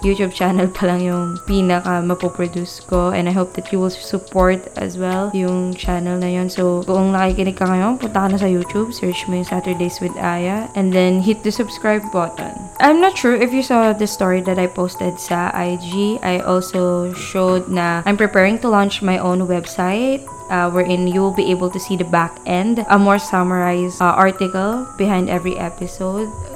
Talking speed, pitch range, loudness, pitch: 195 wpm, 180-200 Hz, -17 LUFS, 185 Hz